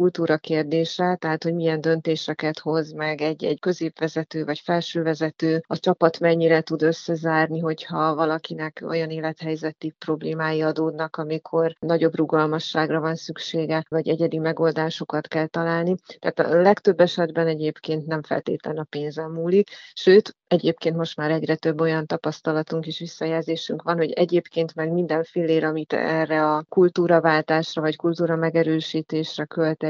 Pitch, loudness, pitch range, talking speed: 160 Hz, -23 LUFS, 155-165 Hz, 135 wpm